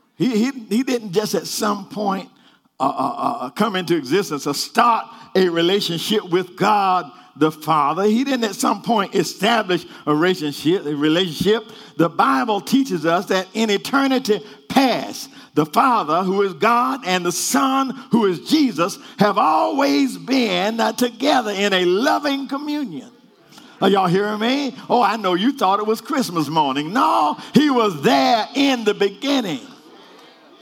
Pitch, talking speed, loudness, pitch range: 215 Hz, 155 wpm, -19 LUFS, 185-250 Hz